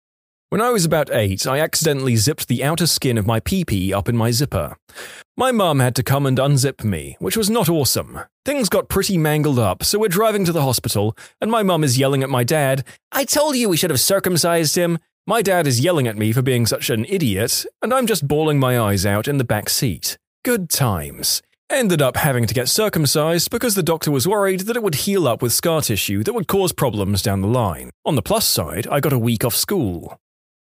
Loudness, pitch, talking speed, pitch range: -18 LUFS, 140 Hz, 230 wpm, 115-180 Hz